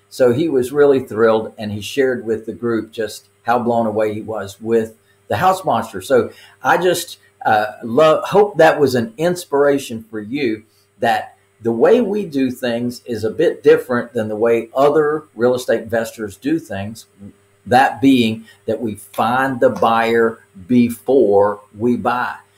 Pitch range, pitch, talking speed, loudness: 110-140 Hz, 115 Hz, 165 wpm, -17 LUFS